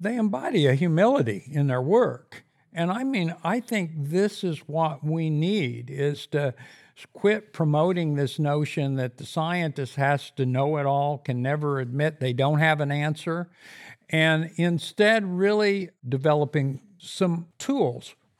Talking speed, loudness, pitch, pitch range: 145 wpm, -25 LUFS, 155 Hz, 145-180 Hz